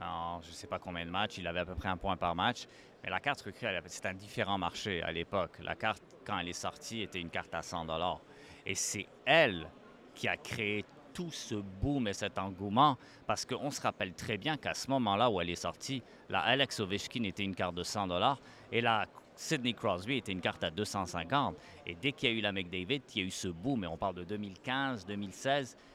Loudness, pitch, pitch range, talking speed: -35 LUFS, 100 Hz, 90-120 Hz, 230 wpm